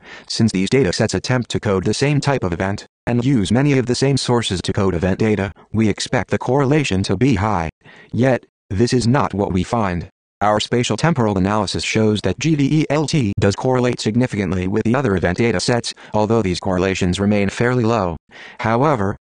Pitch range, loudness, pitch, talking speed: 95-125 Hz, -18 LUFS, 110 Hz, 180 wpm